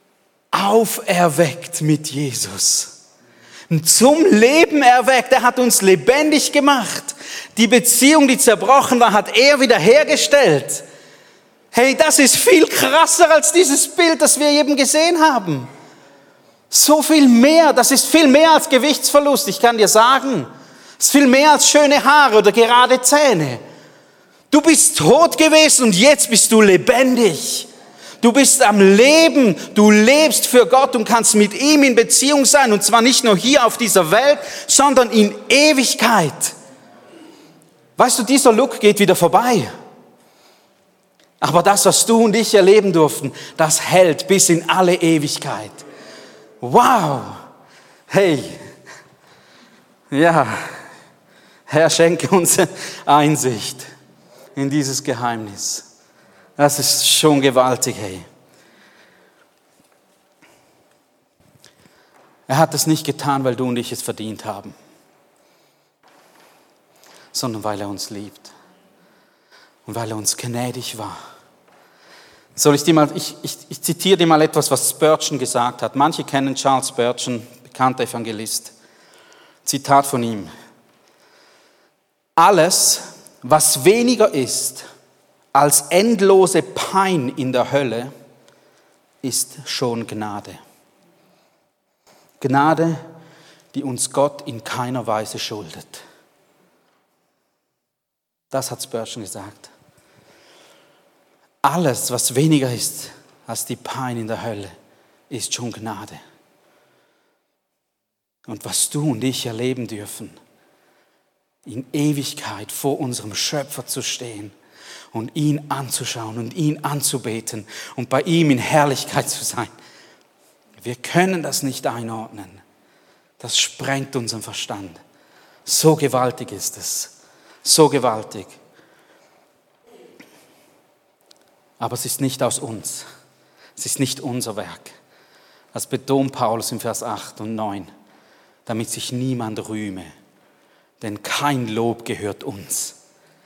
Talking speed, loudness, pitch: 120 wpm, -14 LUFS, 150 Hz